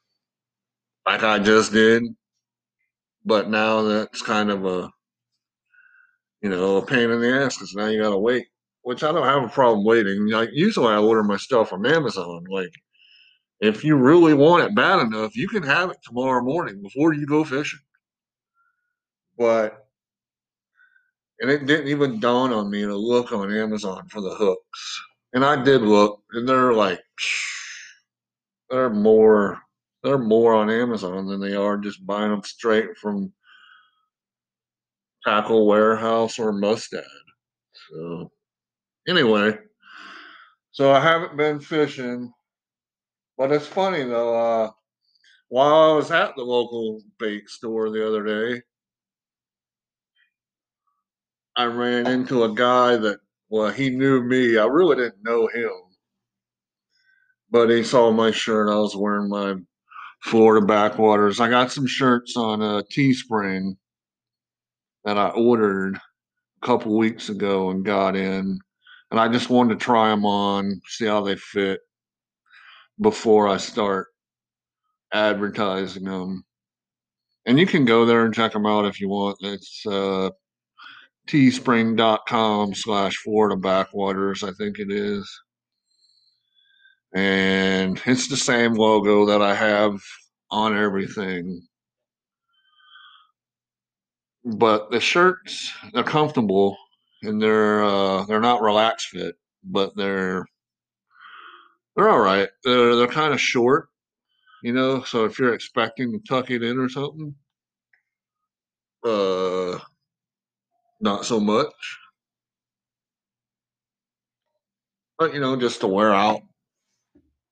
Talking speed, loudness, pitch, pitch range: 130 wpm, -20 LUFS, 110 Hz, 100-130 Hz